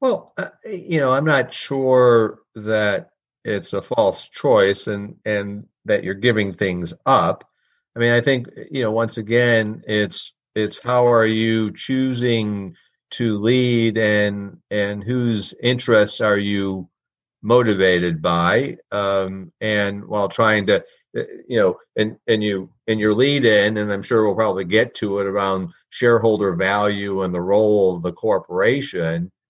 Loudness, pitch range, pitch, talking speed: -19 LUFS, 100-120 Hz, 105 Hz, 150 wpm